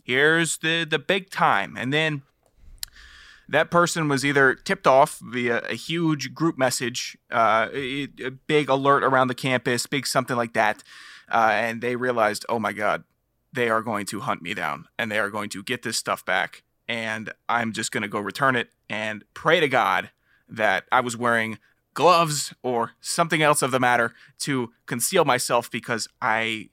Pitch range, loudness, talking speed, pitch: 115-145 Hz, -23 LUFS, 180 wpm, 125 Hz